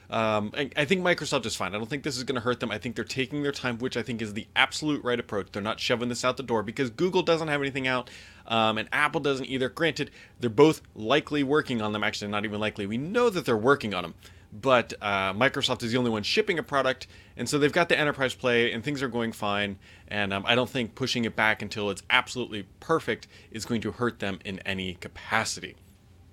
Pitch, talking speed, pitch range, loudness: 120 Hz, 245 wpm, 105-135 Hz, -27 LUFS